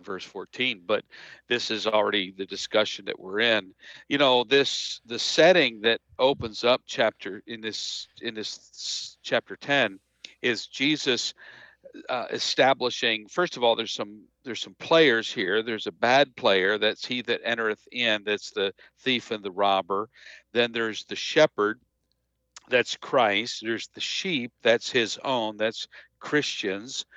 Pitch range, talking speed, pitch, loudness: 105-130 Hz, 150 wpm, 115 Hz, -25 LUFS